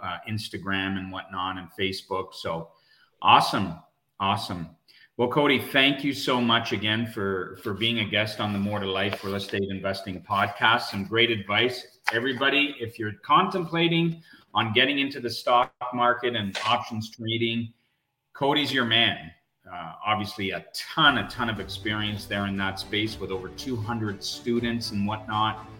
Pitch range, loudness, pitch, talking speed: 100-120 Hz, -25 LUFS, 110 Hz, 155 wpm